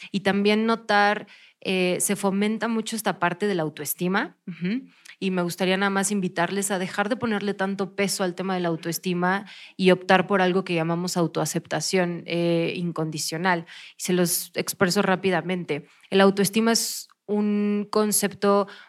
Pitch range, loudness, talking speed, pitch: 175-205 Hz, -24 LUFS, 155 wpm, 190 Hz